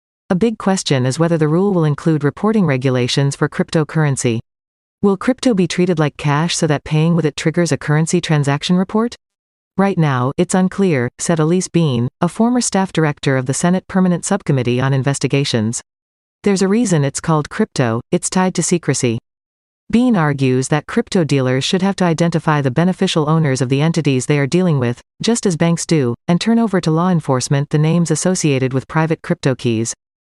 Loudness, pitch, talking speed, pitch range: -16 LUFS, 160 Hz, 185 wpm, 140-185 Hz